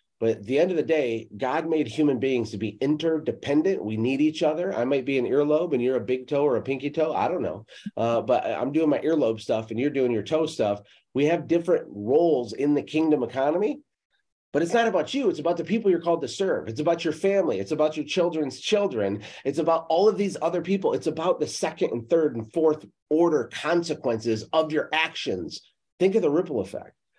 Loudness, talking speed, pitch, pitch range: -25 LUFS, 225 wpm, 150 Hz, 125-165 Hz